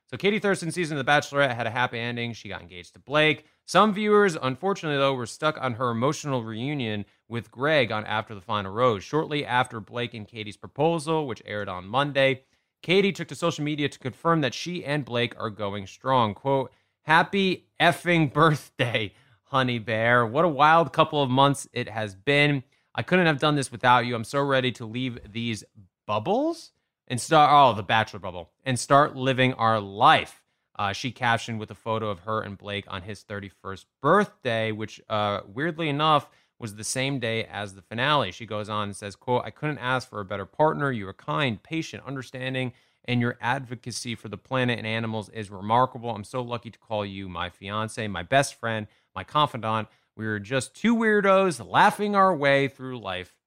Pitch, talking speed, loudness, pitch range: 125 Hz, 195 wpm, -25 LUFS, 110-145 Hz